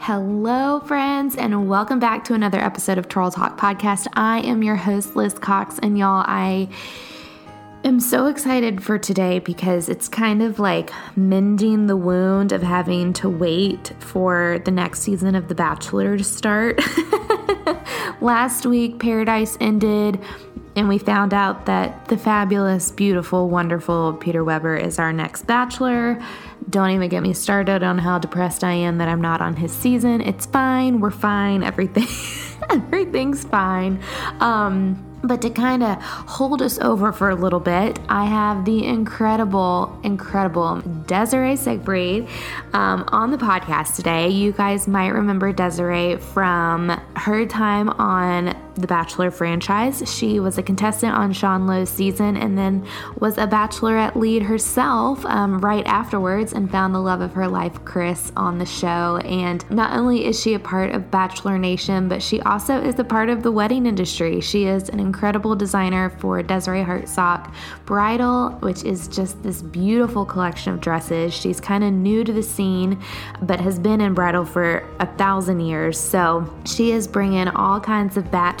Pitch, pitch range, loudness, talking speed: 195 Hz, 180-220 Hz, -20 LUFS, 165 wpm